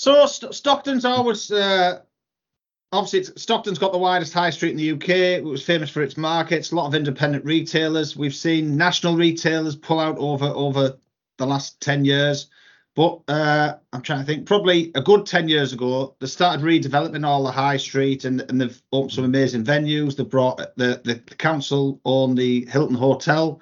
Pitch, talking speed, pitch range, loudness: 150 Hz, 190 wpm, 135-170 Hz, -21 LUFS